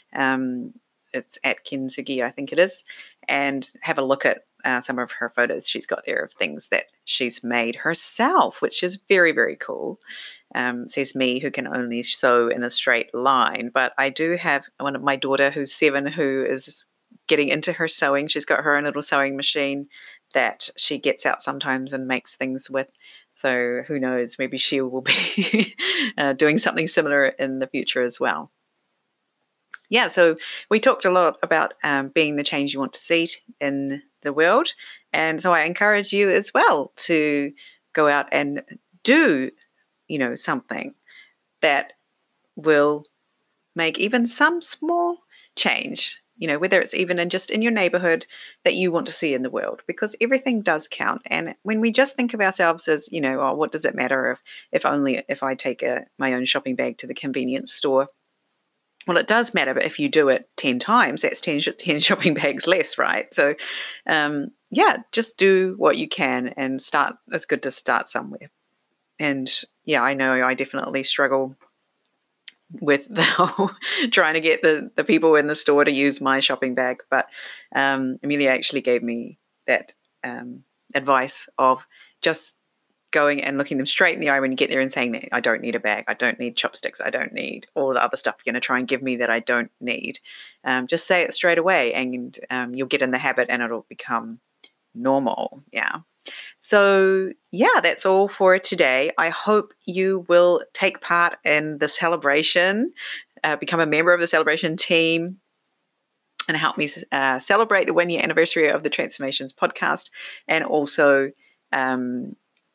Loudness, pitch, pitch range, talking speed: -21 LUFS, 145 Hz, 135-185 Hz, 185 wpm